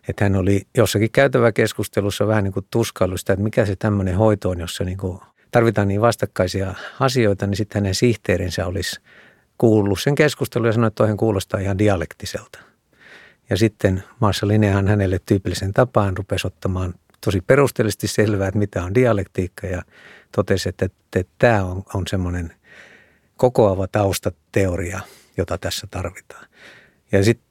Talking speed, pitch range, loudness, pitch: 150 wpm, 95-110 Hz, -20 LUFS, 100 Hz